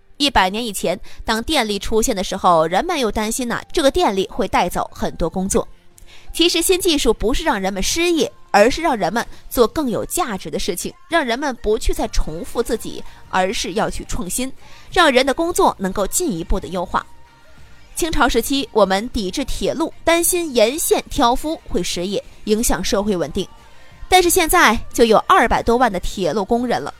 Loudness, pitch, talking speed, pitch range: -18 LUFS, 245 Hz, 280 characters per minute, 215-325 Hz